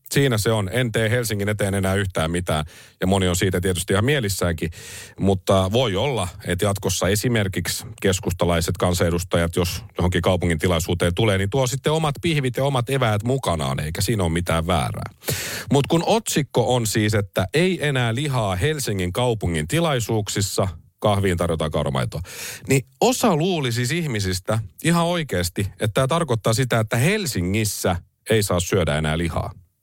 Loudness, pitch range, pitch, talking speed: -22 LUFS, 90-130 Hz, 105 Hz, 155 wpm